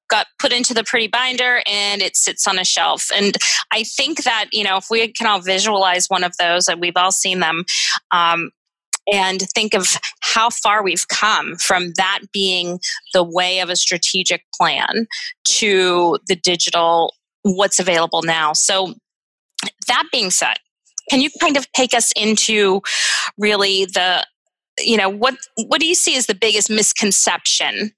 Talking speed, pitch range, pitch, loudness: 165 wpm, 180-225 Hz, 200 Hz, -16 LUFS